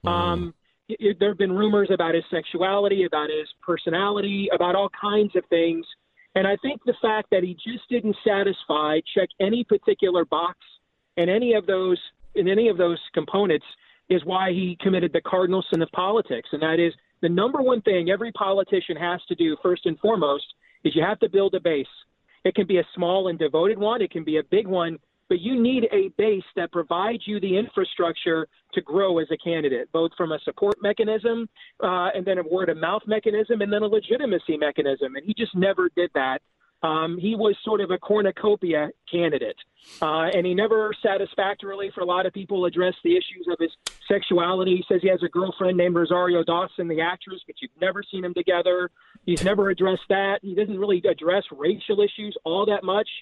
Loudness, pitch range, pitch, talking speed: -23 LUFS, 175-210 Hz, 190 Hz, 200 wpm